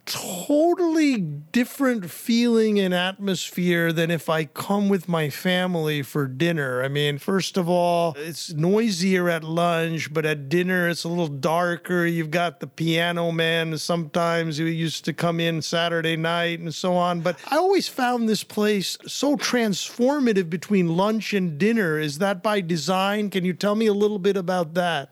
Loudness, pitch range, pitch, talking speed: -23 LUFS, 165-200 Hz, 175 Hz, 170 wpm